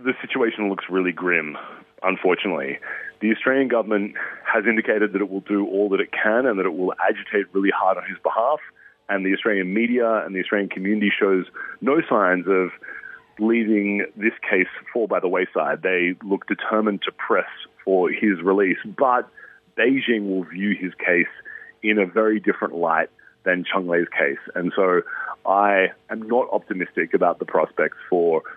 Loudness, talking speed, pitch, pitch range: -21 LUFS, 170 wpm, 100 Hz, 95-110 Hz